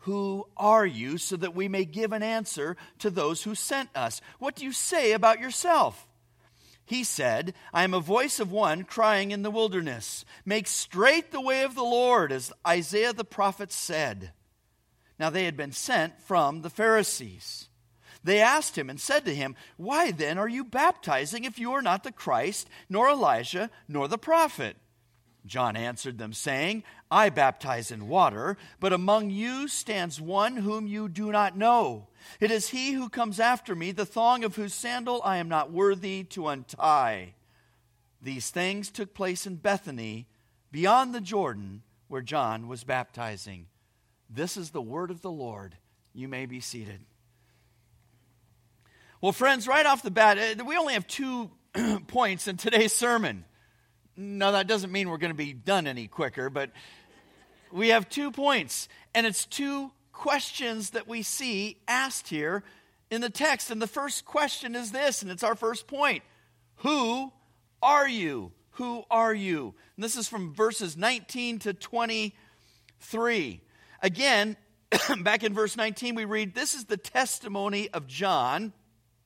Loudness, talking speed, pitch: -27 LUFS, 165 wpm, 200 Hz